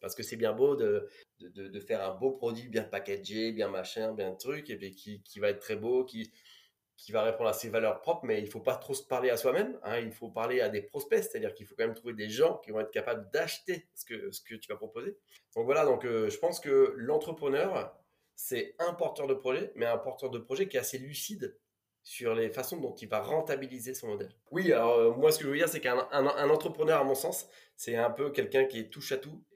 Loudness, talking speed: -32 LUFS, 260 wpm